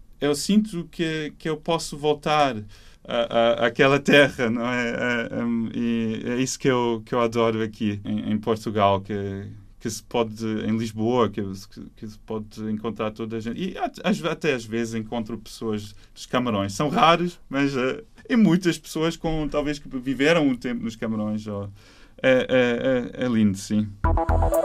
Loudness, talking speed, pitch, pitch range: -24 LUFS, 180 wpm, 115 Hz, 110-150 Hz